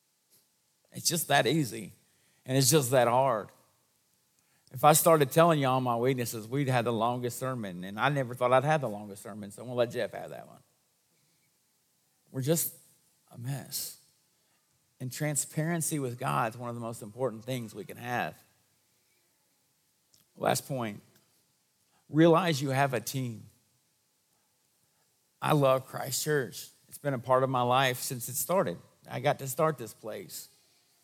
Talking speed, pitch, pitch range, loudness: 160 wpm, 130 Hz, 120-150 Hz, -29 LUFS